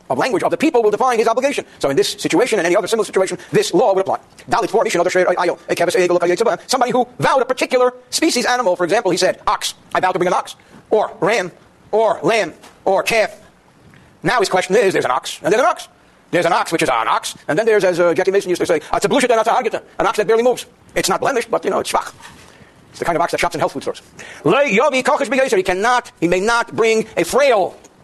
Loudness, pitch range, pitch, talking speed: -17 LUFS, 185-255 Hz, 225 Hz, 230 wpm